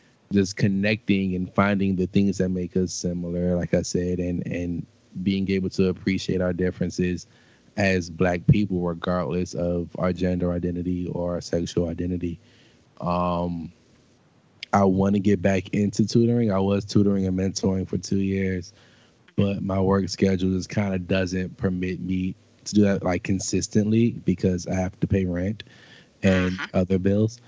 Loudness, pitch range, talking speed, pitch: -24 LUFS, 90-100 Hz, 160 wpm, 95 Hz